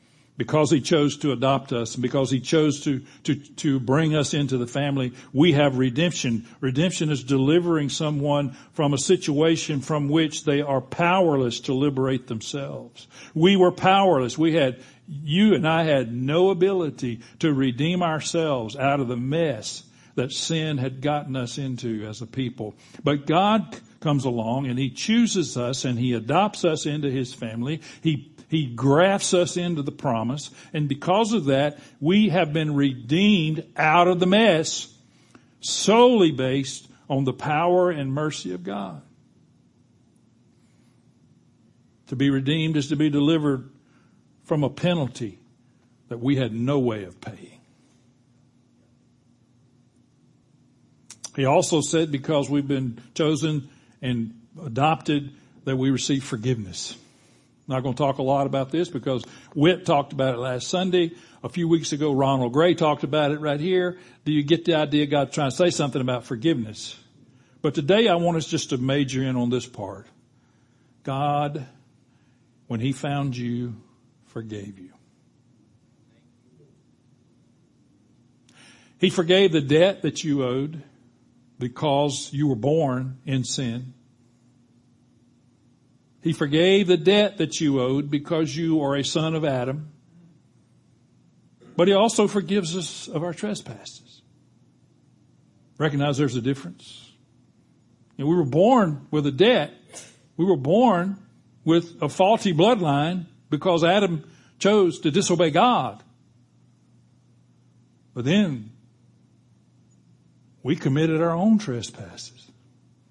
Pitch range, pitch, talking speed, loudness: 125-160 Hz, 140 Hz, 140 wpm, -23 LUFS